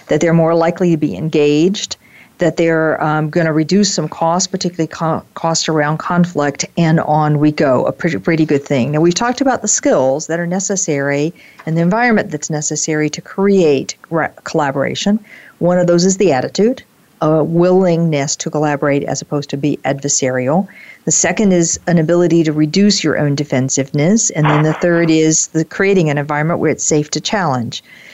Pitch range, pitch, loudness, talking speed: 150-180 Hz, 160 Hz, -14 LUFS, 180 wpm